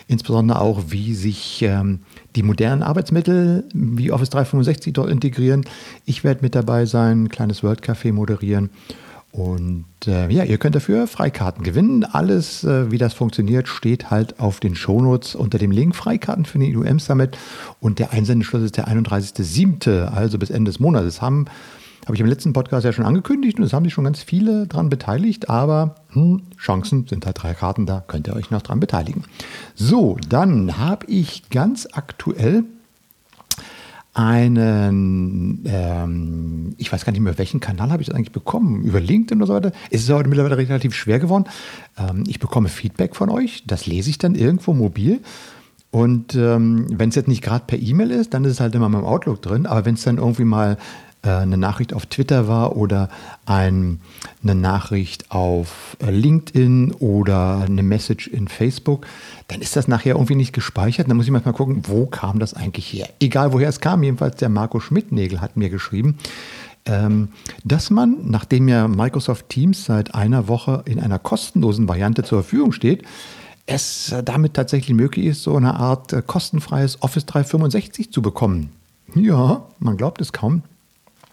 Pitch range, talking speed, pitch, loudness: 105-145 Hz, 175 wpm, 120 Hz, -19 LUFS